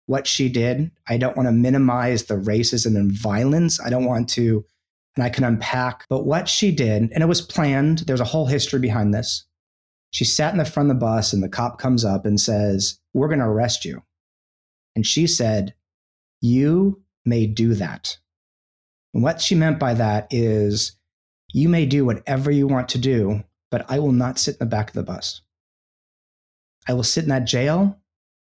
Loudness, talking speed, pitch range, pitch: -20 LUFS, 195 wpm, 100-135 Hz, 120 Hz